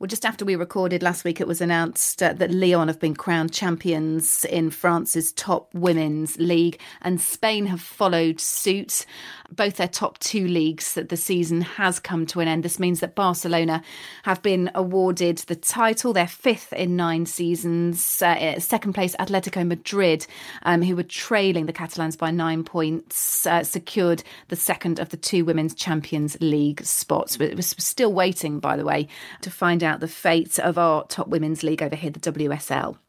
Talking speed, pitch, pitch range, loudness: 180 wpm, 170 Hz, 165-185 Hz, -23 LUFS